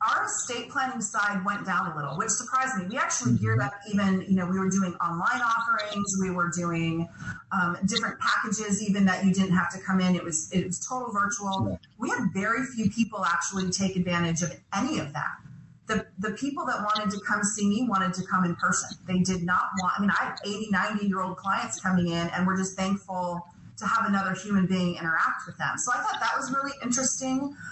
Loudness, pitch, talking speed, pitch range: -27 LUFS, 195 Hz, 225 wpm, 180-215 Hz